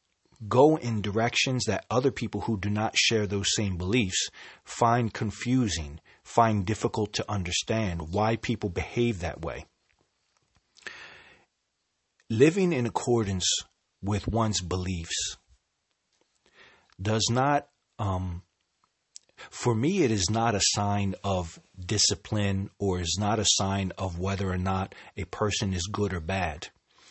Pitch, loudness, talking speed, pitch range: 105 Hz, -27 LUFS, 125 wpm, 95-115 Hz